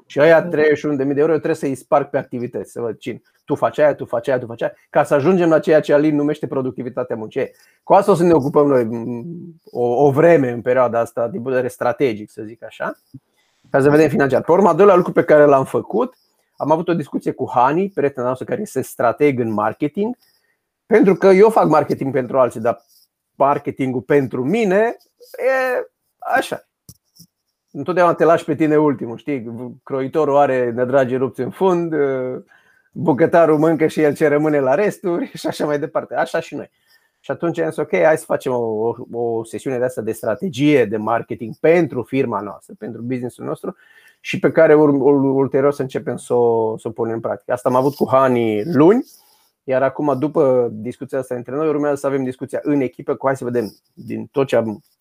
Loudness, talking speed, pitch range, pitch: -17 LUFS, 200 wpm, 125-160 Hz, 140 Hz